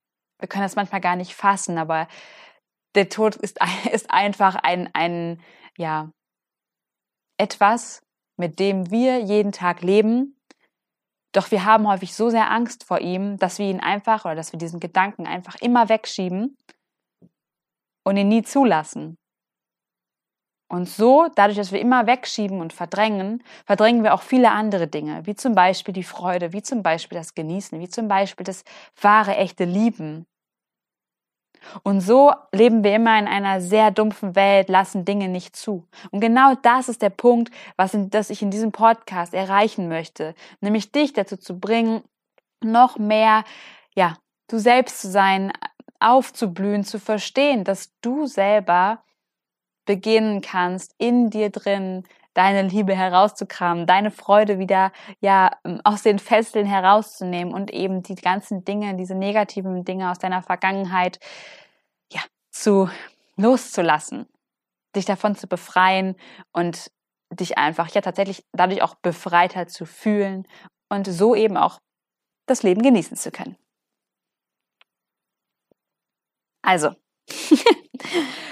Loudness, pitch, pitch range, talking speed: -20 LUFS, 200 Hz, 185-220 Hz, 135 wpm